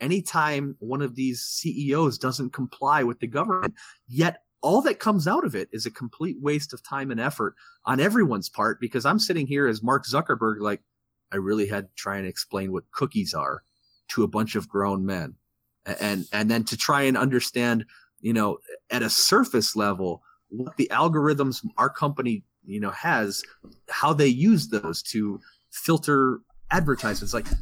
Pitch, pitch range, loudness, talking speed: 125 Hz, 105-145 Hz, -25 LUFS, 175 wpm